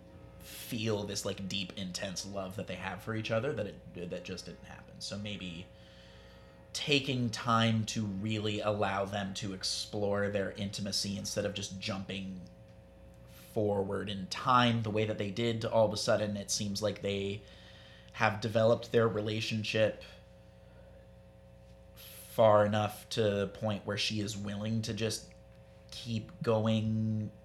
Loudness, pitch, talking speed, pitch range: -33 LUFS, 105 Hz, 145 wpm, 95-110 Hz